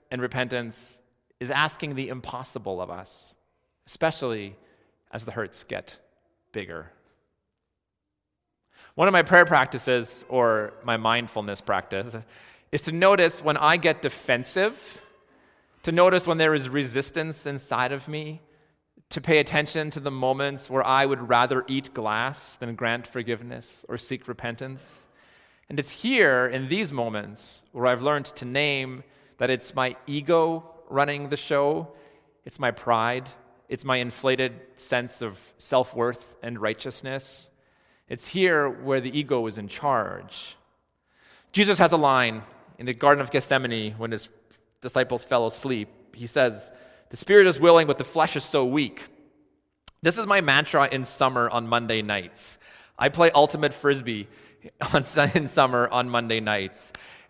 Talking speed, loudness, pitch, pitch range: 145 wpm, -24 LUFS, 130 Hz, 120-145 Hz